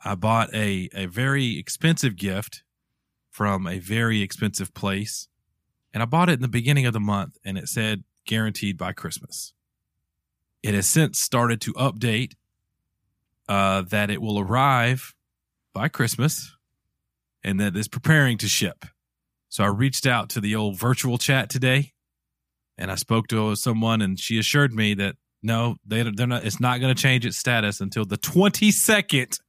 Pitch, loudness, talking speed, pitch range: 110 Hz, -23 LUFS, 165 wpm, 100-130 Hz